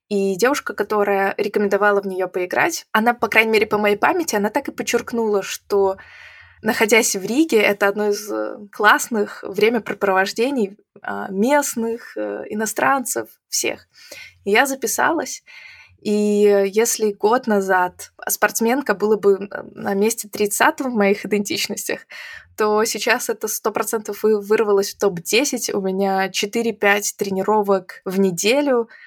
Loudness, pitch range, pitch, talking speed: -19 LUFS, 200-230 Hz, 210 Hz, 120 wpm